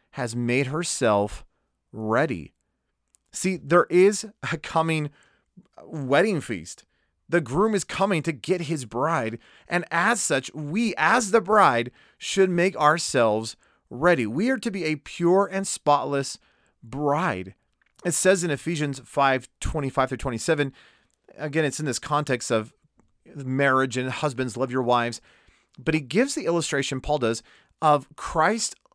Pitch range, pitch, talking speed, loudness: 130-175 Hz, 150 Hz, 140 wpm, -24 LUFS